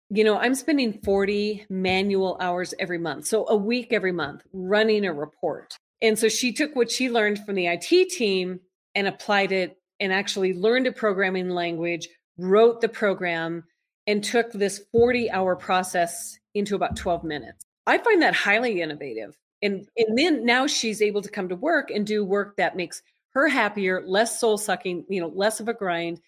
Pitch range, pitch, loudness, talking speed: 185-225 Hz, 200 Hz, -24 LUFS, 185 wpm